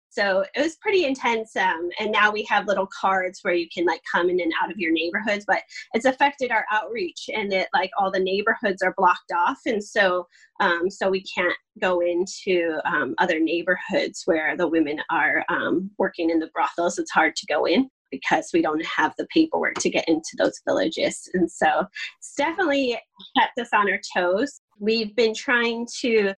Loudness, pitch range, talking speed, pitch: -23 LUFS, 180-240 Hz, 195 wpm, 200 Hz